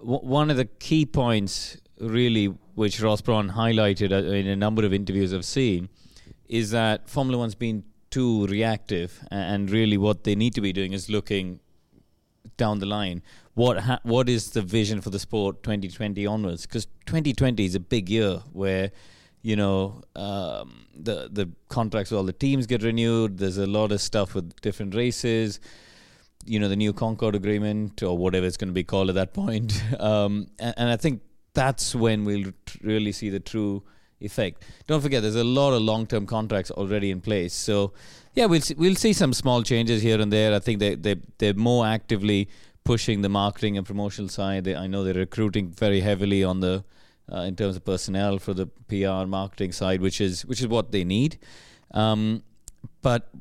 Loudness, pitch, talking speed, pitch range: -25 LUFS, 105 Hz, 190 wpm, 100-115 Hz